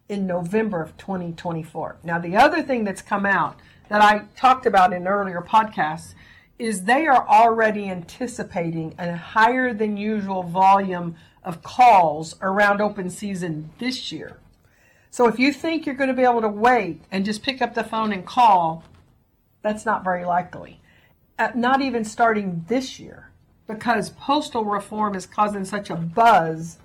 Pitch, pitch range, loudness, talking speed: 210 Hz, 180-235 Hz, -21 LUFS, 160 wpm